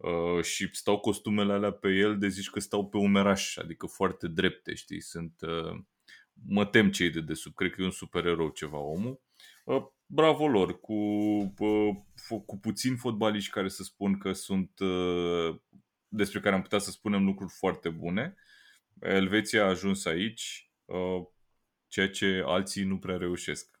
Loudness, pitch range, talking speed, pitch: -30 LUFS, 90-105 Hz, 150 wpm, 100 Hz